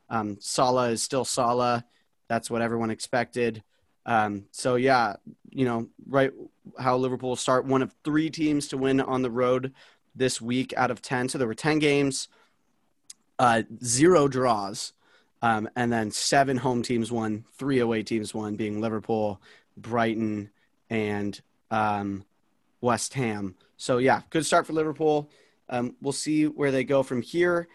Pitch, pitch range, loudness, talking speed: 125 Hz, 110-135 Hz, -26 LUFS, 155 wpm